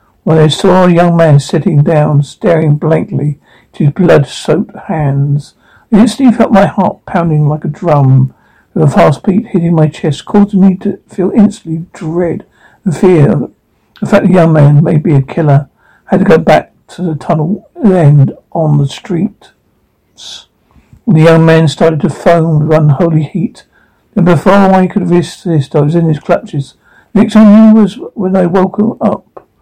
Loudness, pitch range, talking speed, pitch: -9 LUFS, 155-195 Hz, 175 wpm, 170 Hz